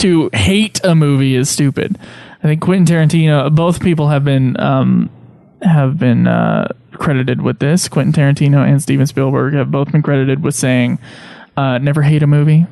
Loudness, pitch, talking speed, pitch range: -13 LUFS, 145 Hz, 175 wpm, 135-160 Hz